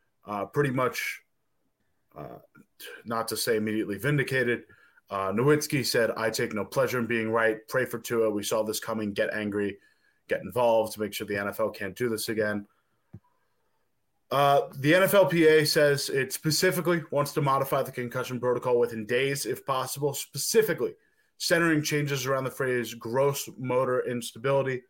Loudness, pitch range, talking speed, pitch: -27 LUFS, 110-145 Hz, 155 wpm, 125 Hz